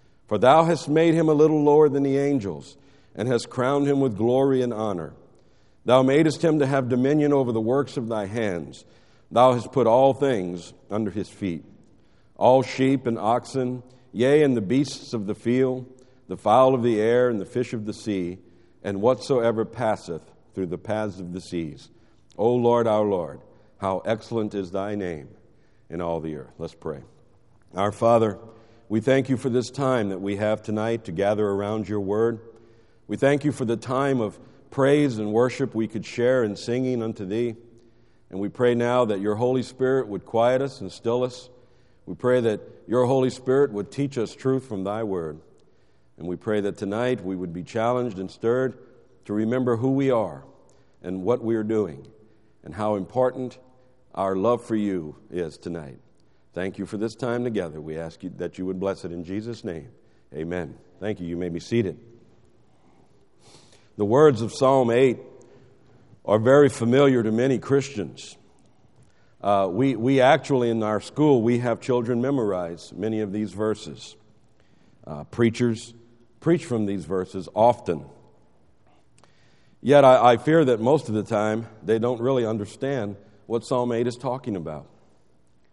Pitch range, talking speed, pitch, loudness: 100-130 Hz, 175 wpm, 115 Hz, -23 LUFS